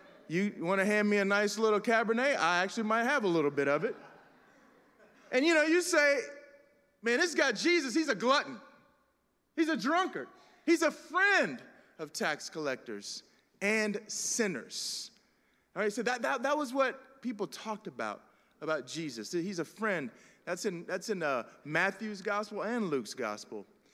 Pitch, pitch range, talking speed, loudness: 225 Hz, 200-285 Hz, 170 wpm, -31 LUFS